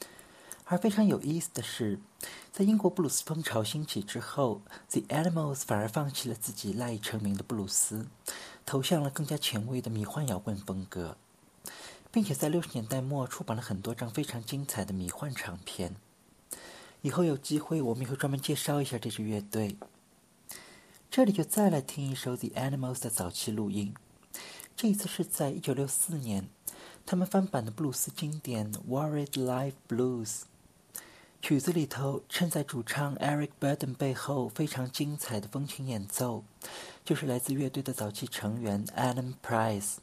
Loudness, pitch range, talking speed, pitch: -32 LUFS, 110-150 Hz, 315 characters per minute, 130 Hz